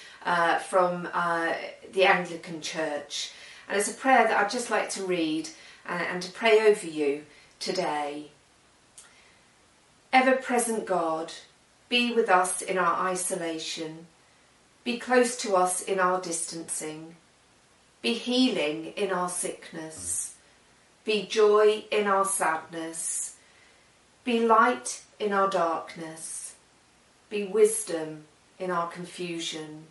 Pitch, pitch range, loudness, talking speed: 180 Hz, 165-210 Hz, -27 LUFS, 120 wpm